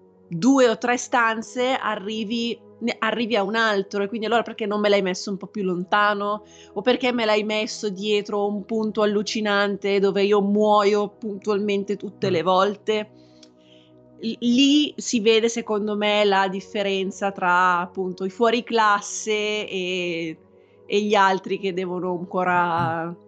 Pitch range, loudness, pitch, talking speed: 190-220 Hz, -22 LUFS, 205 Hz, 150 wpm